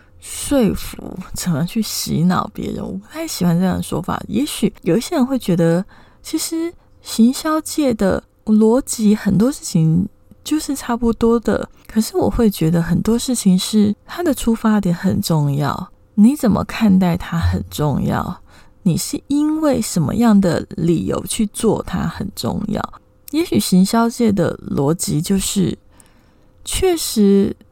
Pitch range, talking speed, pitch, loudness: 180-240 Hz, 220 characters per minute, 210 Hz, -18 LUFS